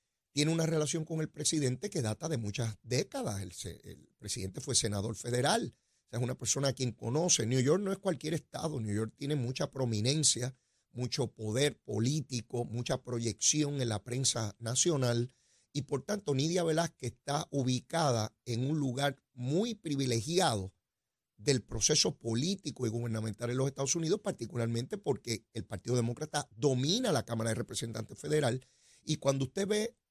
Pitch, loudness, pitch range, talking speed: 130 Hz, -33 LUFS, 115-150 Hz, 160 wpm